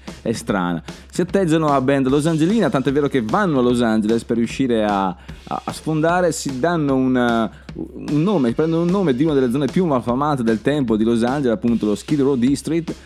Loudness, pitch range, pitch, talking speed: -19 LUFS, 120-160 Hz, 140 Hz, 200 wpm